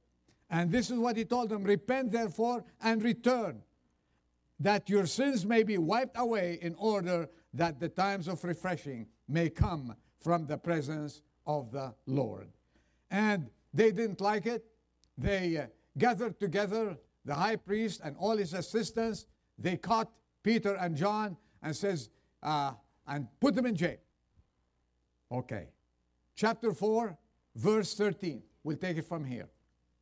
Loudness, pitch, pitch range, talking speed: -33 LUFS, 180 Hz, 140-220 Hz, 145 wpm